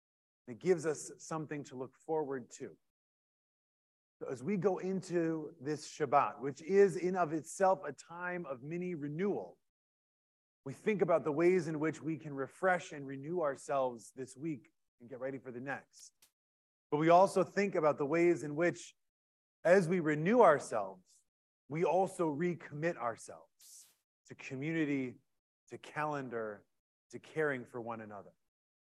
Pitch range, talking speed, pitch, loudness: 130-175 Hz, 145 wpm, 150 Hz, -35 LUFS